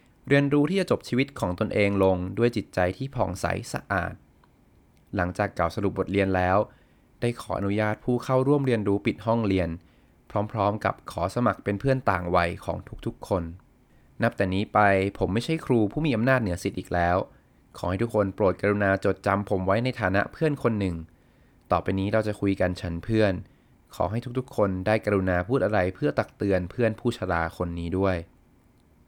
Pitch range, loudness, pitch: 90-115 Hz, -26 LUFS, 100 Hz